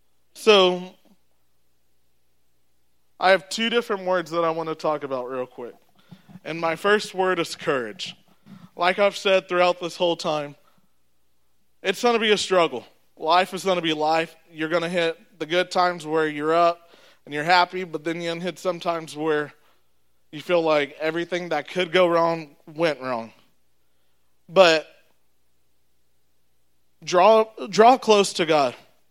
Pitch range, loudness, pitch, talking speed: 120-180 Hz, -22 LUFS, 165 Hz, 160 wpm